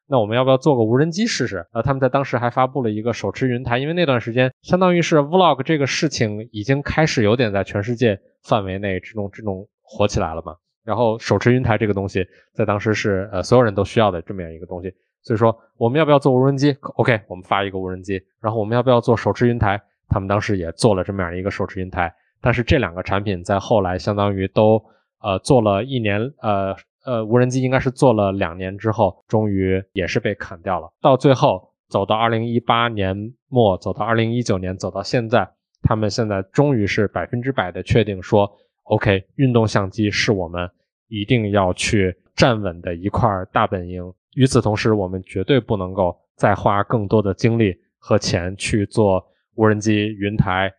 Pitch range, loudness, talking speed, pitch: 95-120 Hz, -19 LUFS, 325 characters per minute, 105 Hz